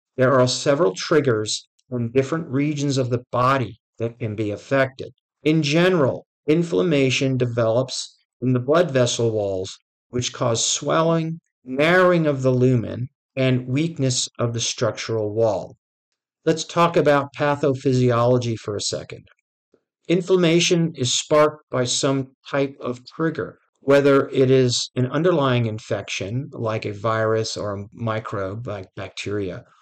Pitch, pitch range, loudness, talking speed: 130 Hz, 115-145 Hz, -21 LUFS, 130 wpm